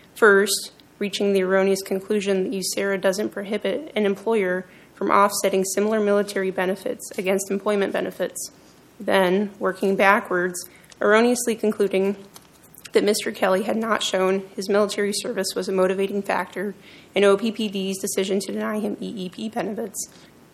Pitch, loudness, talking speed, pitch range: 200 Hz, -22 LUFS, 130 wpm, 190-210 Hz